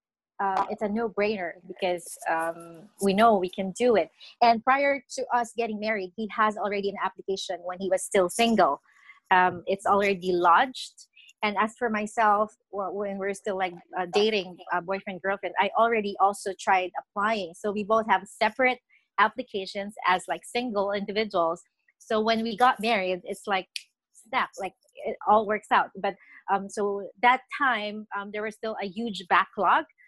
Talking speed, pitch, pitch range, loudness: 175 wpm, 205 Hz, 190-225 Hz, -26 LUFS